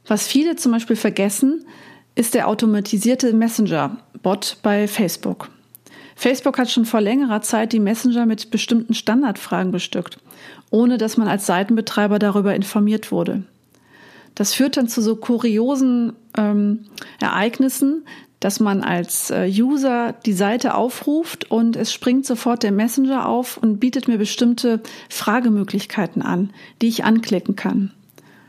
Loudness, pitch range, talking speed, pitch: -19 LUFS, 210-245 Hz, 135 wpm, 225 Hz